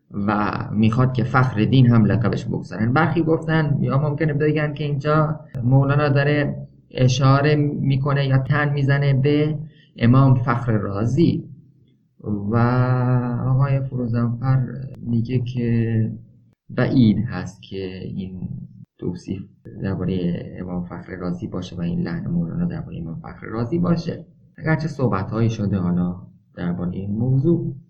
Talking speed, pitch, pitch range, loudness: 125 wpm, 130 Hz, 110-150 Hz, -21 LUFS